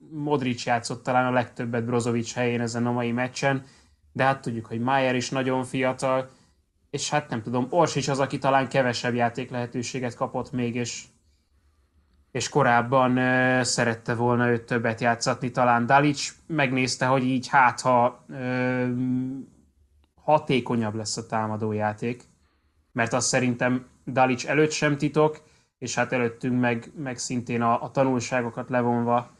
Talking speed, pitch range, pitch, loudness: 145 wpm, 120-130 Hz, 125 Hz, -25 LUFS